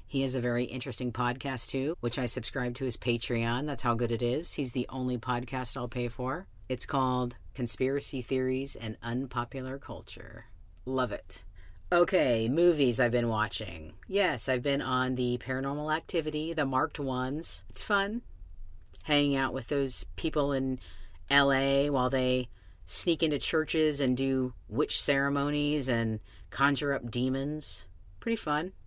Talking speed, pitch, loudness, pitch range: 150 wpm, 130 Hz, -30 LUFS, 120-140 Hz